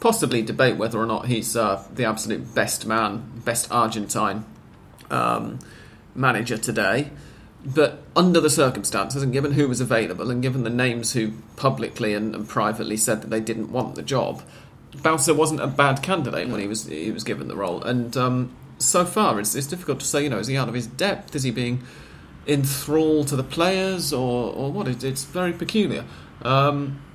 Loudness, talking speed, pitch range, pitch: -23 LUFS, 190 wpm, 115-145 Hz, 125 Hz